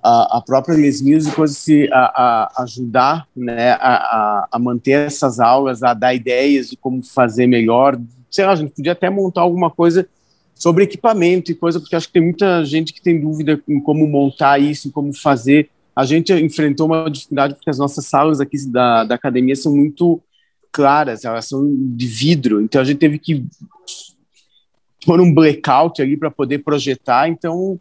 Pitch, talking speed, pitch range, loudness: 145 Hz, 185 wpm, 135-165 Hz, -15 LUFS